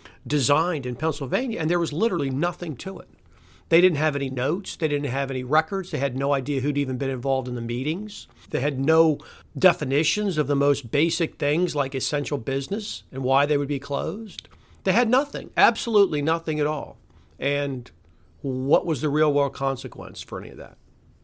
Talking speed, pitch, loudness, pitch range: 190 wpm, 145 Hz, -24 LUFS, 135-165 Hz